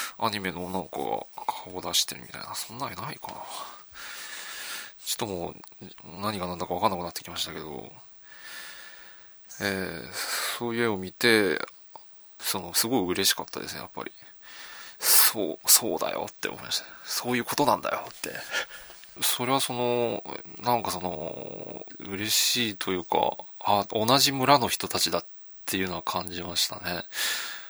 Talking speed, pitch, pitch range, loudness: 305 characters per minute, 100 Hz, 90-120 Hz, -27 LUFS